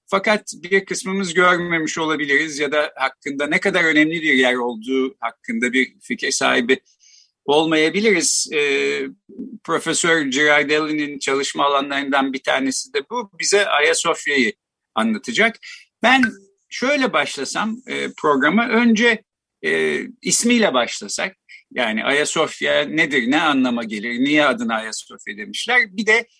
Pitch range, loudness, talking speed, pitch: 140-225 Hz, -18 LUFS, 120 wpm, 165 Hz